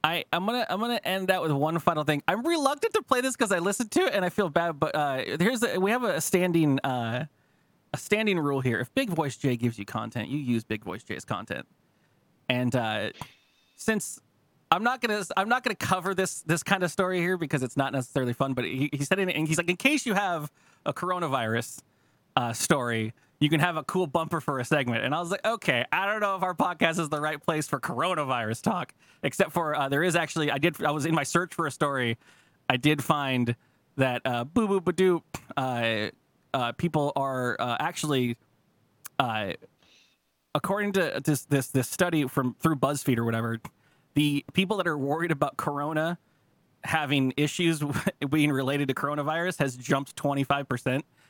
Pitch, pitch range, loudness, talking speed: 150 Hz, 135-180 Hz, -27 LUFS, 200 wpm